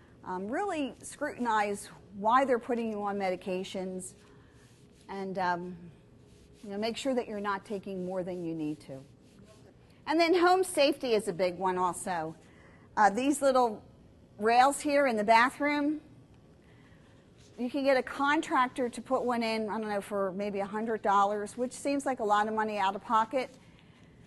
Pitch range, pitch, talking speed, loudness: 195-260 Hz, 220 Hz, 170 wpm, -30 LUFS